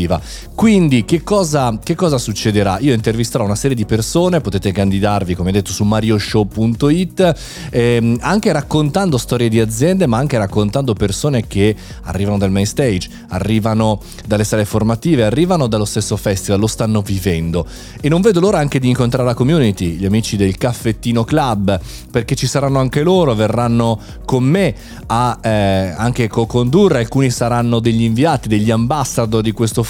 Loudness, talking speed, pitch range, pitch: -15 LUFS, 160 wpm, 105-140 Hz, 115 Hz